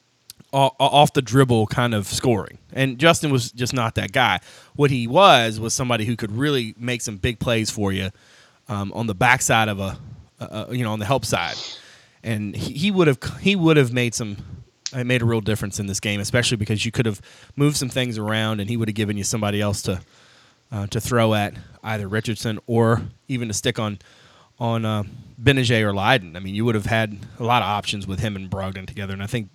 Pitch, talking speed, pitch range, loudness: 115 Hz, 220 wpm, 105-125 Hz, -21 LUFS